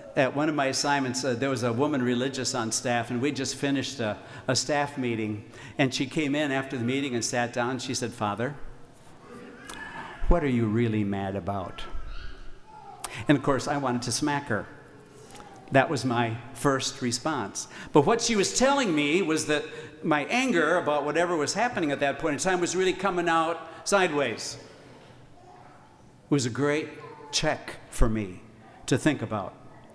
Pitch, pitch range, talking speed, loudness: 135 Hz, 120-150 Hz, 175 wpm, -27 LUFS